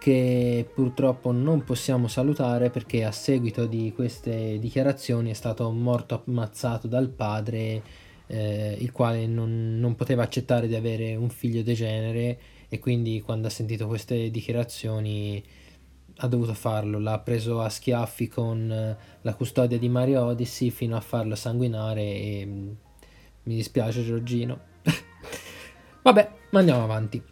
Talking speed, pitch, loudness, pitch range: 135 wpm, 115 Hz, -26 LUFS, 110-125 Hz